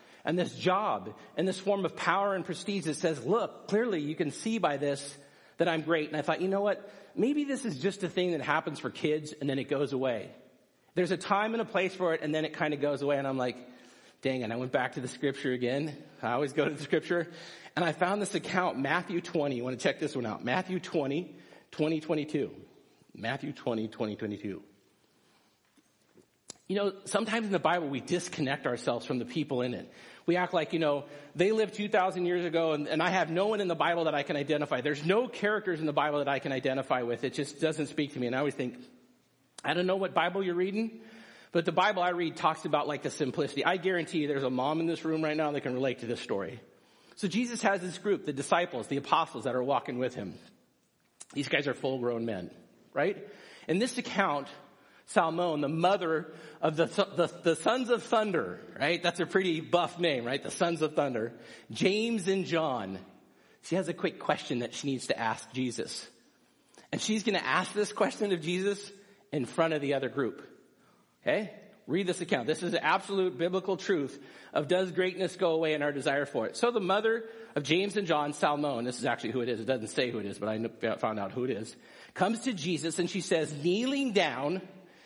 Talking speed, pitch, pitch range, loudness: 225 wpm, 165 Hz, 140-190 Hz, -31 LUFS